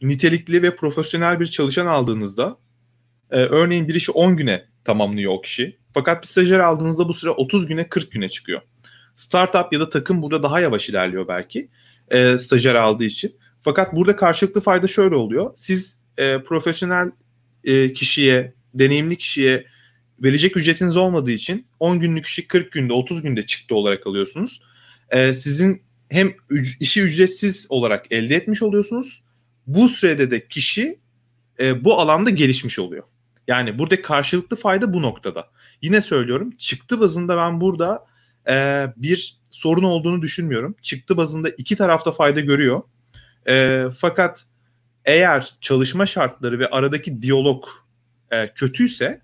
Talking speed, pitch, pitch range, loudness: 145 wpm, 145 Hz, 120-175 Hz, -19 LUFS